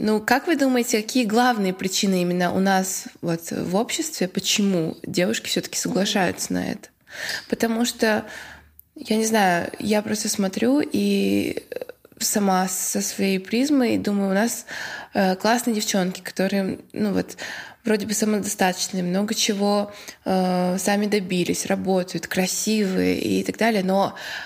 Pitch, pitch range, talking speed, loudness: 205 Hz, 185-225 Hz, 135 wpm, -22 LUFS